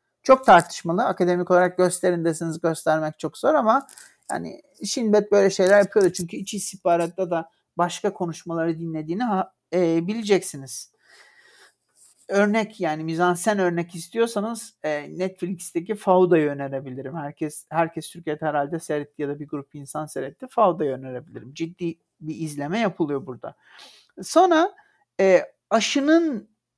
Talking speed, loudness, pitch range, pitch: 115 wpm, -23 LUFS, 155-205 Hz, 175 Hz